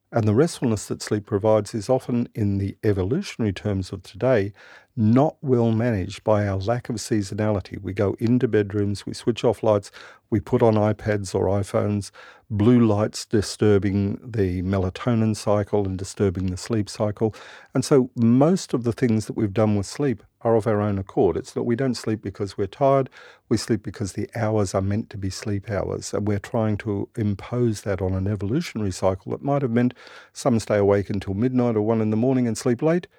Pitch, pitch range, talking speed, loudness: 110 Hz, 100-120 Hz, 195 wpm, -23 LUFS